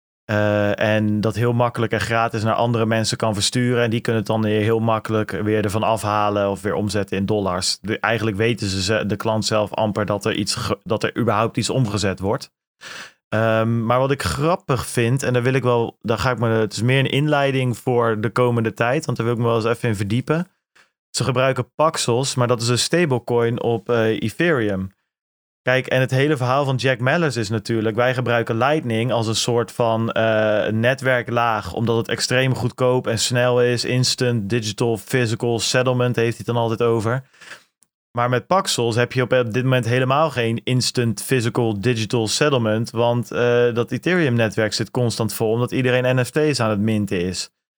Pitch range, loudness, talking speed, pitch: 110-125 Hz, -20 LUFS, 195 wpm, 115 Hz